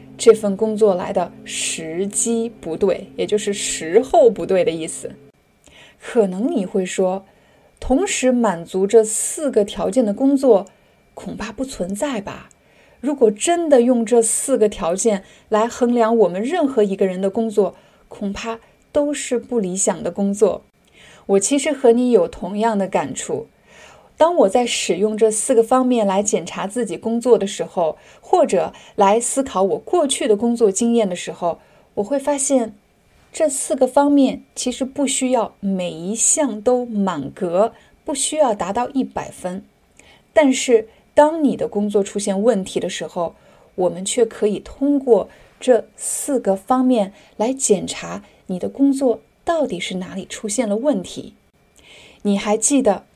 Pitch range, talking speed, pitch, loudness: 200-260 Hz, 225 characters per minute, 225 Hz, -19 LUFS